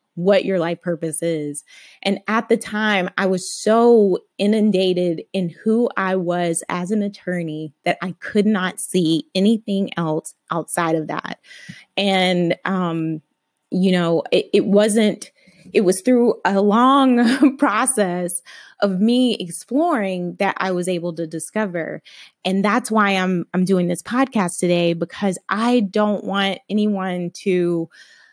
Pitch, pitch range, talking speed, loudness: 190 Hz, 175-210 Hz, 140 wpm, -19 LUFS